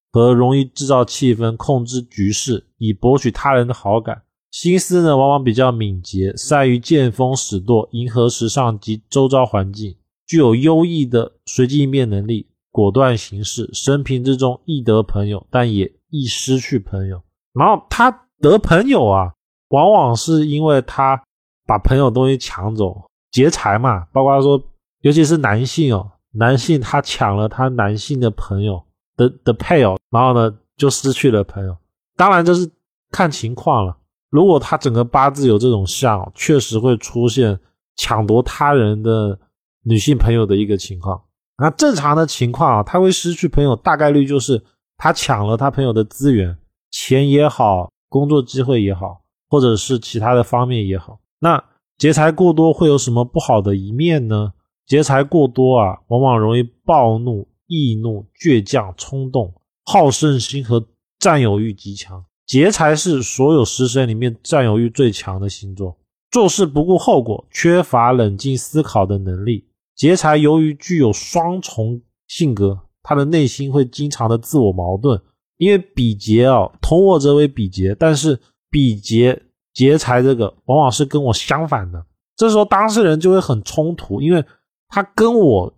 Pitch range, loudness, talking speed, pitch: 105-145 Hz, -15 LUFS, 245 characters per minute, 125 Hz